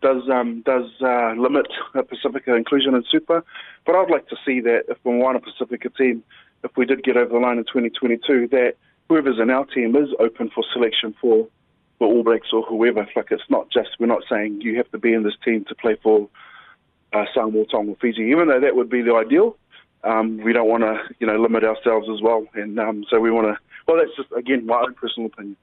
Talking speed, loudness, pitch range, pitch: 230 wpm, -20 LUFS, 110-125 Hz, 115 Hz